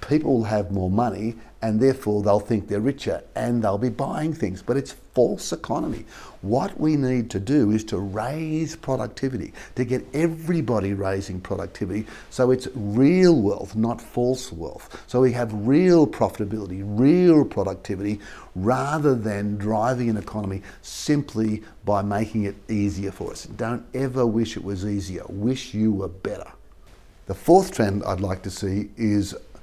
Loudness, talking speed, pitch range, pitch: -23 LUFS, 160 wpm, 100-130 Hz, 110 Hz